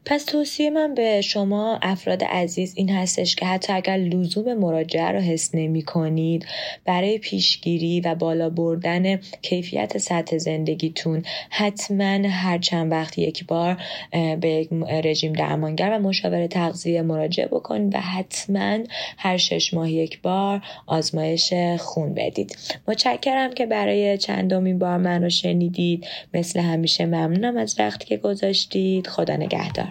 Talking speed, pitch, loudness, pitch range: 135 wpm, 175 Hz, -22 LUFS, 165-195 Hz